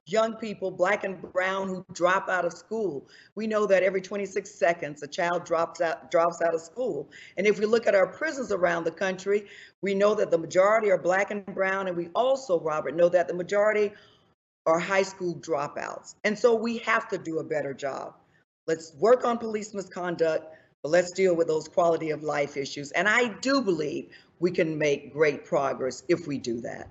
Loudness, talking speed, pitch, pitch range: -27 LUFS, 205 wpm, 185 Hz, 165-205 Hz